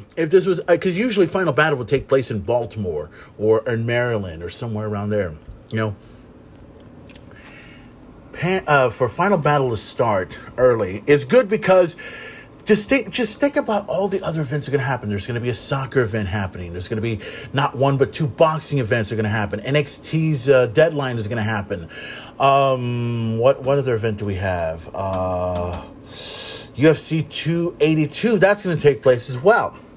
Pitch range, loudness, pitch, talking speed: 110-155 Hz, -20 LUFS, 135 Hz, 190 wpm